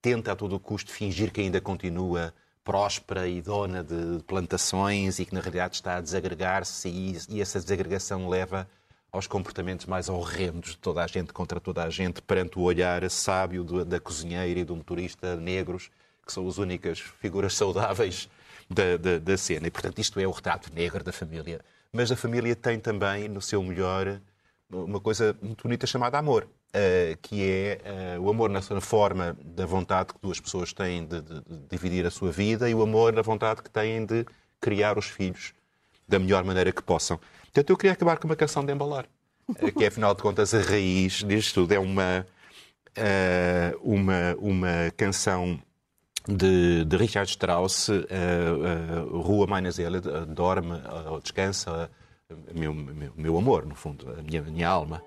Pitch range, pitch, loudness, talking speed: 90-100 Hz, 95 Hz, -27 LUFS, 180 wpm